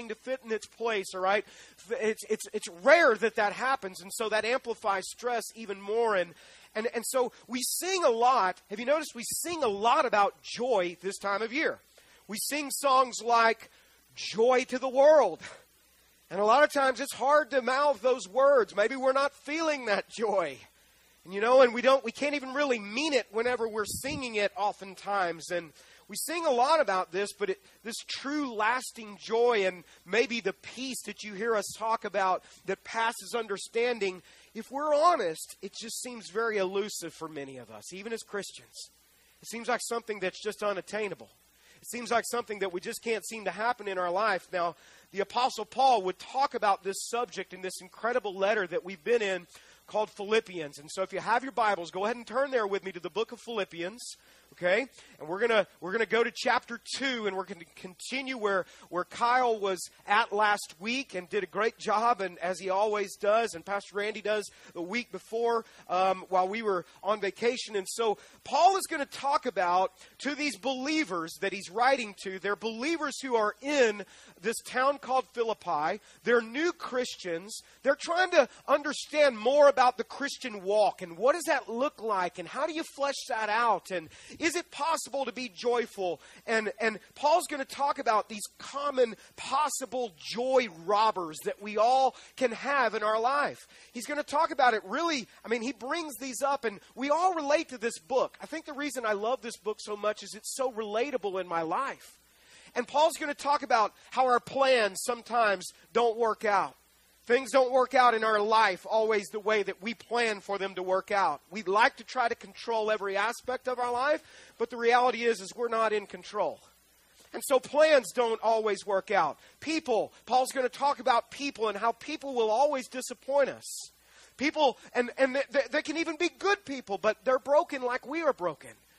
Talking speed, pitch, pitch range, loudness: 200 wpm, 230 Hz, 200-260 Hz, -29 LUFS